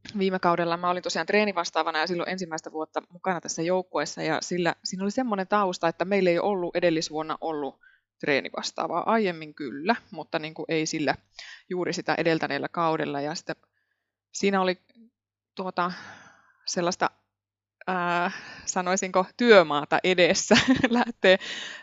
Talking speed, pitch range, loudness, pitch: 130 wpm, 160-195 Hz, -26 LUFS, 175 Hz